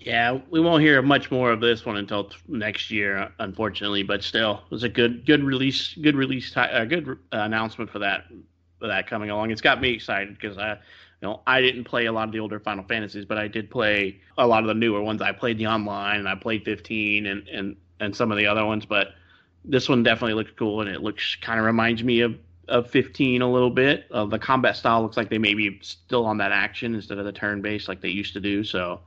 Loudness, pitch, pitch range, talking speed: -23 LUFS, 110 Hz, 105-120 Hz, 245 wpm